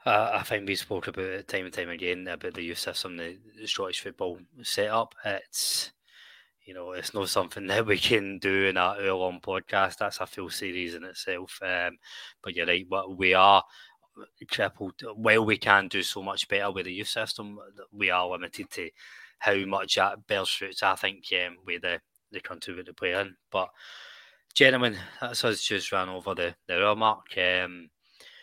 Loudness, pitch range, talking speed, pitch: -27 LUFS, 90-100 Hz, 195 wpm, 95 Hz